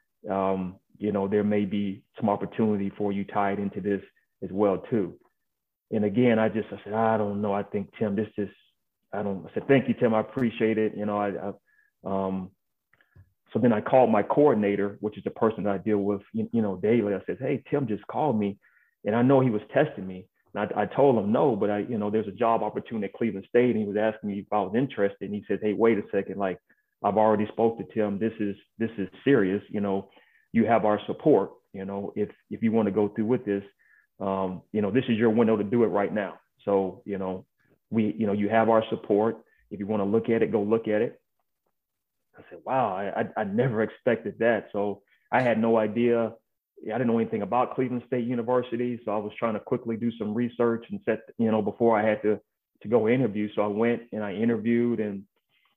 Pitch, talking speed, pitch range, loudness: 105 Hz, 235 wpm, 100-115 Hz, -26 LUFS